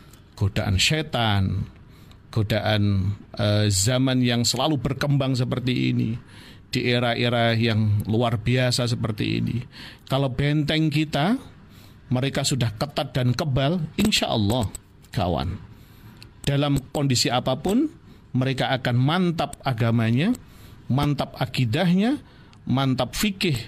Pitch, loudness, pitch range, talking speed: 125 Hz, -23 LUFS, 110-140 Hz, 100 wpm